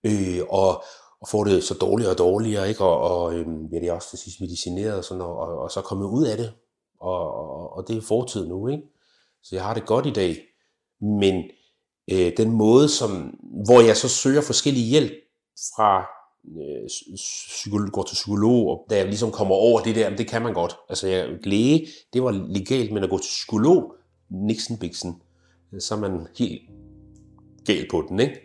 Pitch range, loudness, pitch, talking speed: 95-115 Hz, -22 LUFS, 105 Hz, 200 wpm